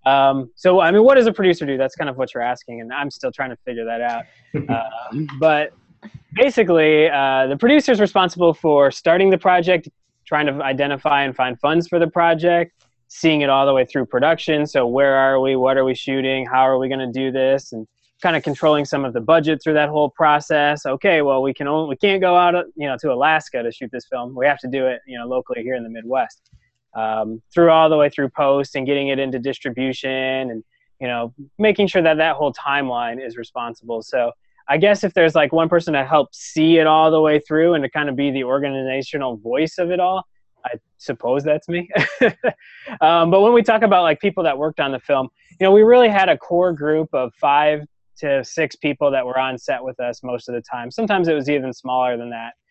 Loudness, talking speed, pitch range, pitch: -18 LUFS, 230 wpm, 130-165 Hz, 145 Hz